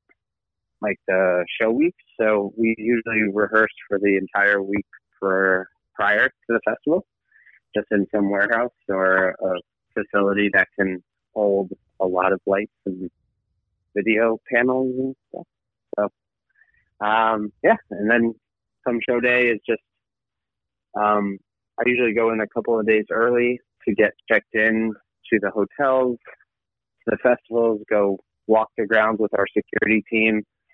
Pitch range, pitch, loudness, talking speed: 100-115 Hz, 110 Hz, -21 LUFS, 145 wpm